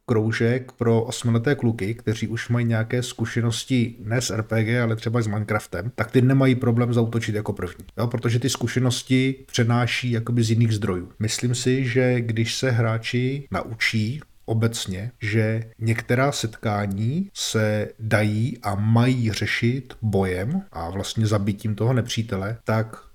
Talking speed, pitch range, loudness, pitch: 145 wpm, 110-125 Hz, -23 LUFS, 115 Hz